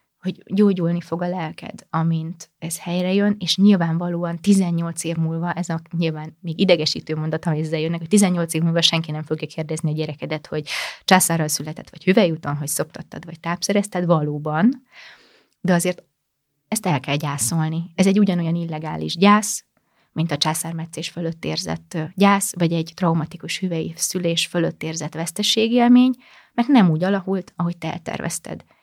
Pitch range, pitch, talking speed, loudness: 160-185 Hz, 170 Hz, 155 wpm, -21 LUFS